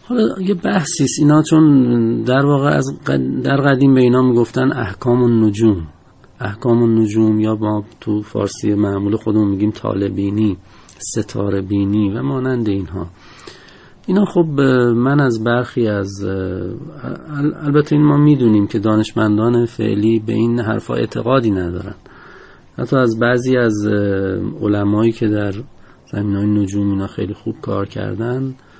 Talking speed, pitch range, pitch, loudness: 135 wpm, 100-130 Hz, 115 Hz, -16 LUFS